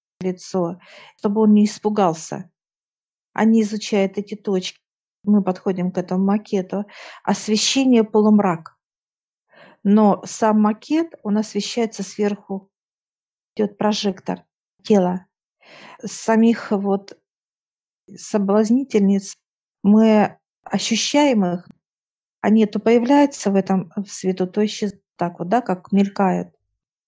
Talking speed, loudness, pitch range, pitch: 100 wpm, -19 LUFS, 190-215 Hz, 205 Hz